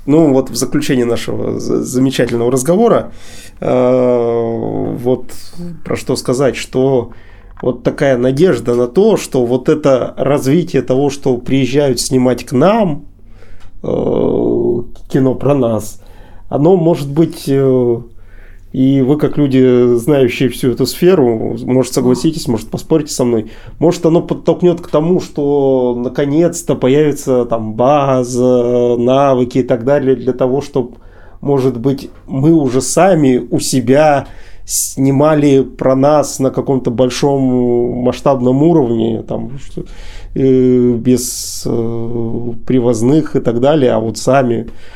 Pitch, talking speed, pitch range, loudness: 130 Hz, 120 wpm, 120-145 Hz, -13 LUFS